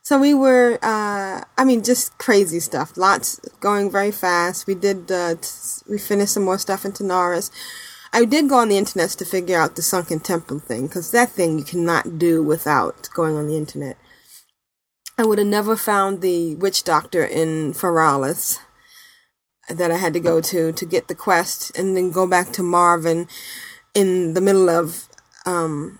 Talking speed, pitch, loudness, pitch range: 180 wpm, 185 Hz, -19 LUFS, 170-205 Hz